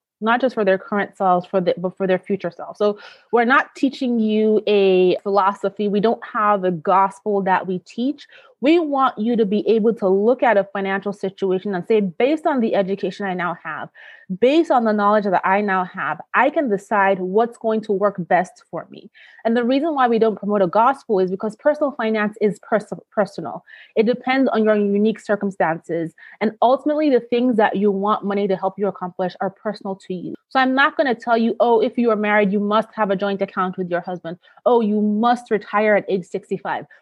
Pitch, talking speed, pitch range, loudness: 205 Hz, 215 wpm, 195-230 Hz, -19 LUFS